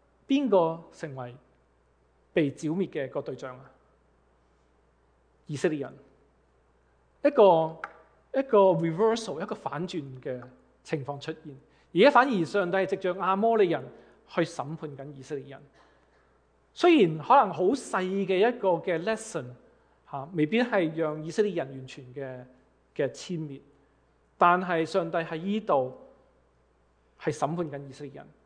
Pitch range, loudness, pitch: 125-185 Hz, -27 LUFS, 155 Hz